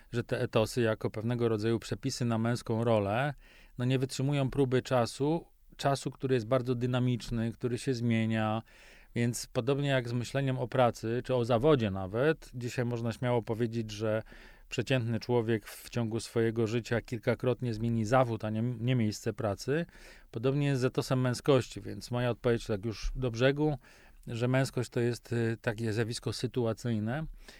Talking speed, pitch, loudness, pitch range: 160 wpm, 120 Hz, -32 LUFS, 115-130 Hz